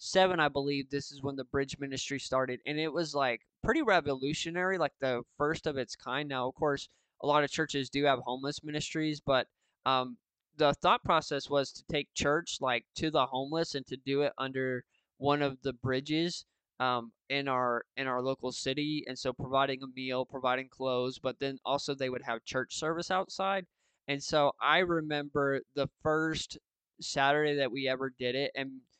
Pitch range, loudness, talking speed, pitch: 130-150 Hz, -32 LUFS, 190 wpm, 140 Hz